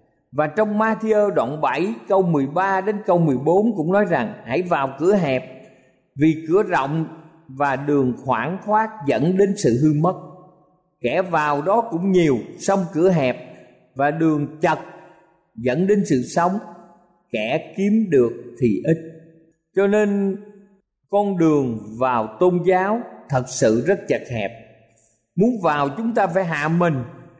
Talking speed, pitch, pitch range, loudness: 150 wpm, 170 Hz, 140-195 Hz, -20 LUFS